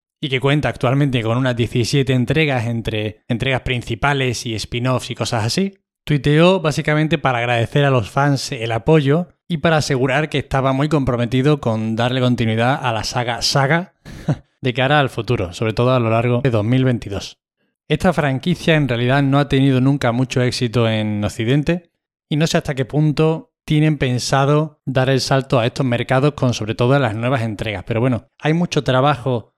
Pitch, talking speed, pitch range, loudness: 130 Hz, 175 wpm, 120-150 Hz, -18 LUFS